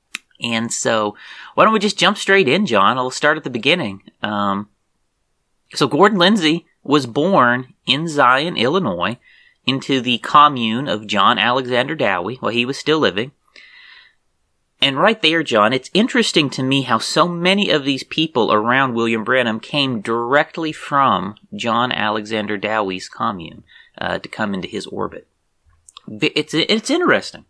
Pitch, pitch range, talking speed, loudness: 135 Hz, 115-165 Hz, 155 wpm, -17 LUFS